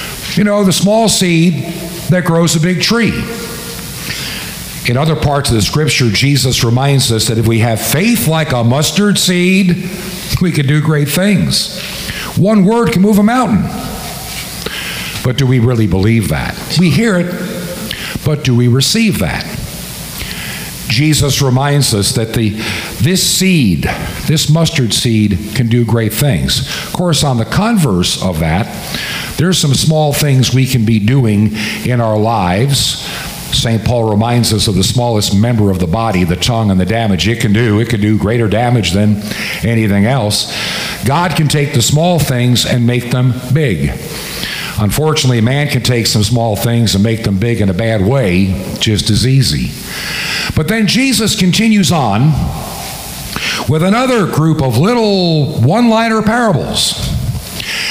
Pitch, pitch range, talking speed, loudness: 135 Hz, 115-170 Hz, 155 wpm, -12 LUFS